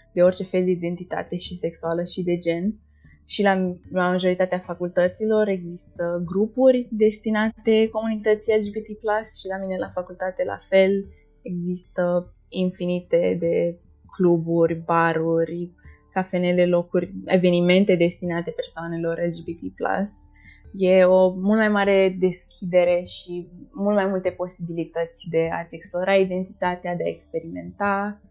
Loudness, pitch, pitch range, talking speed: -23 LUFS, 180 Hz, 170-195 Hz, 115 wpm